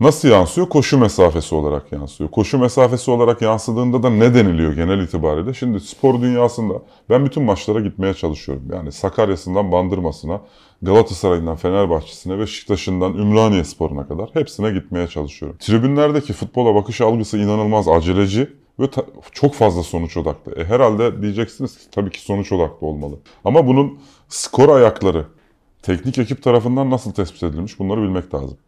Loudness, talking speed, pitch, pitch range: -17 LUFS, 145 wpm, 105 Hz, 90-125 Hz